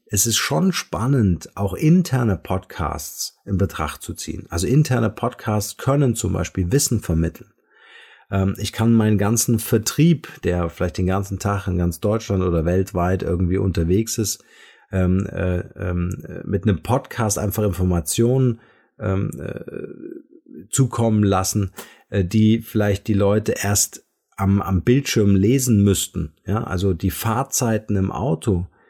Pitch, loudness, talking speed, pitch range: 100 Hz, -20 LUFS, 140 wpm, 95-115 Hz